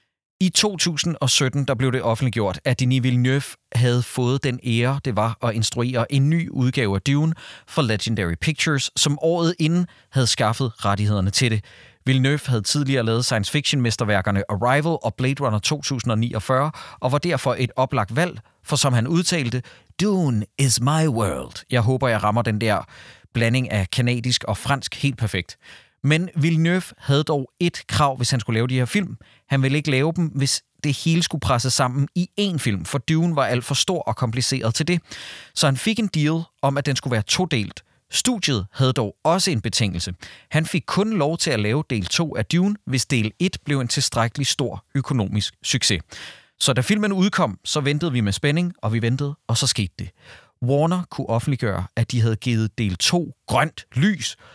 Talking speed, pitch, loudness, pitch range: 190 wpm, 130 Hz, -21 LUFS, 115-150 Hz